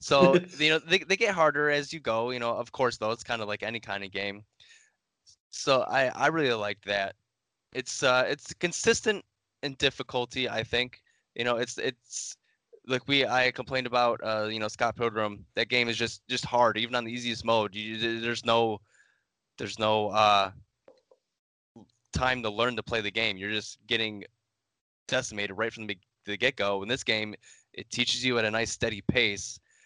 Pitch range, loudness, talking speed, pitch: 110-130 Hz, -28 LUFS, 195 wpm, 115 Hz